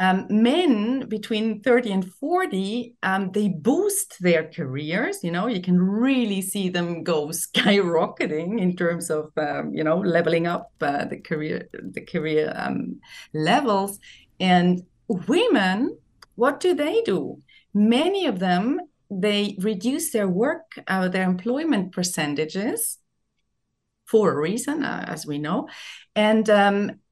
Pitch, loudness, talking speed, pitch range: 200 Hz, -23 LUFS, 135 wpm, 175-240 Hz